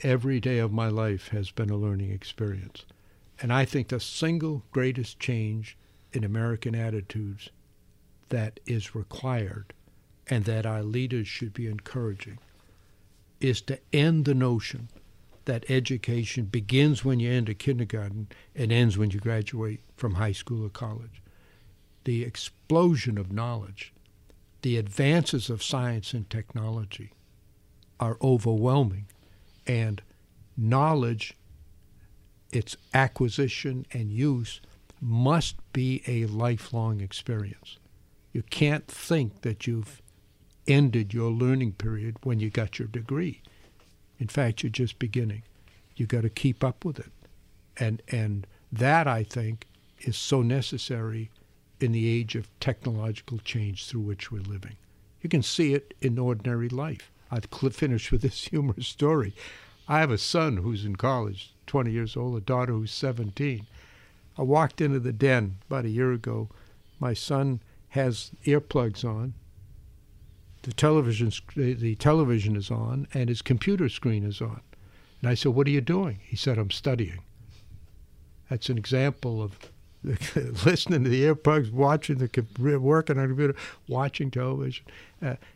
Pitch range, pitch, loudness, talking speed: 105-130 Hz, 115 Hz, -28 LUFS, 140 wpm